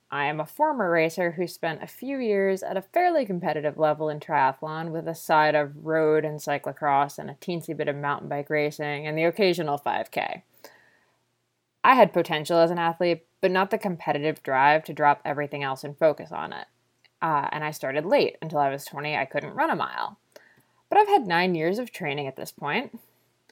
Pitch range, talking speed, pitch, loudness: 145-180 Hz, 200 wpm, 155 Hz, -25 LUFS